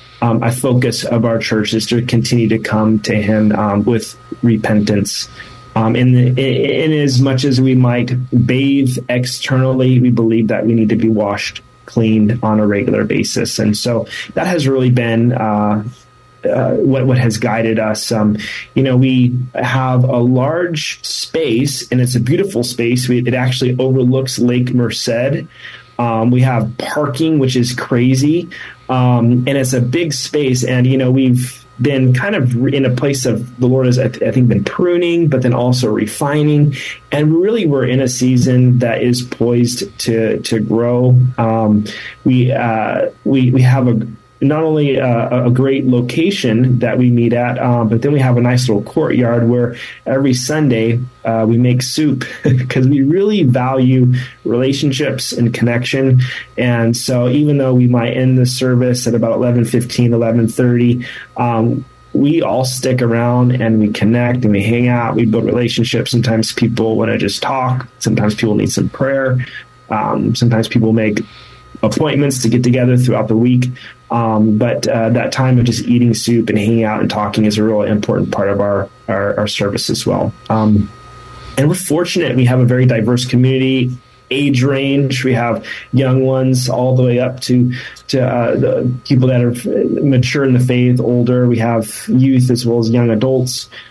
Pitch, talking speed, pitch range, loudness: 125 Hz, 175 wpm, 115-130 Hz, -14 LUFS